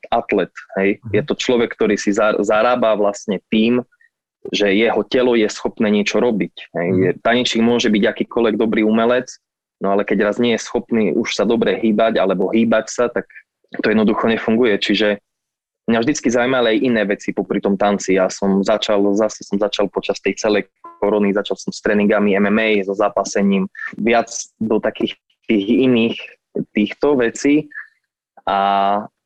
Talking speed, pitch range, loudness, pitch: 155 wpm, 100-115 Hz, -17 LUFS, 105 Hz